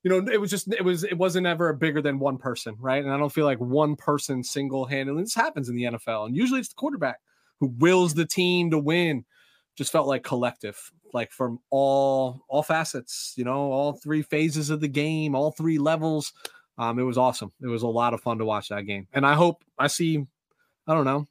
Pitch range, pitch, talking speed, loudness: 130-160 Hz, 145 Hz, 230 wpm, -25 LUFS